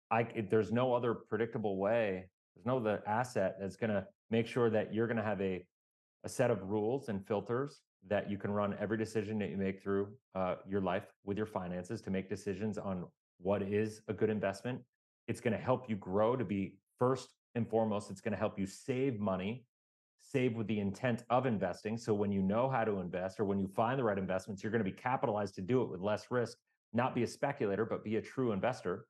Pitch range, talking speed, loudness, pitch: 100-115 Hz, 225 wpm, -36 LUFS, 105 Hz